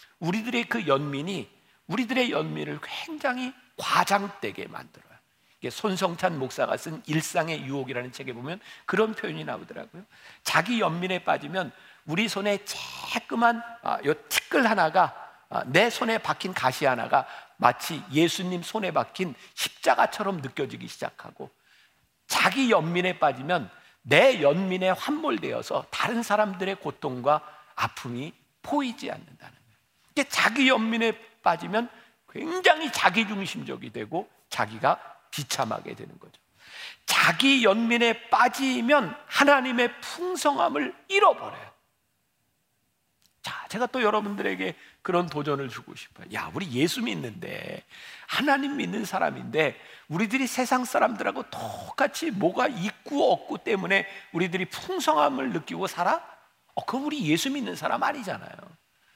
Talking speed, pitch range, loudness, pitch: 290 characters per minute, 175-255 Hz, -26 LUFS, 215 Hz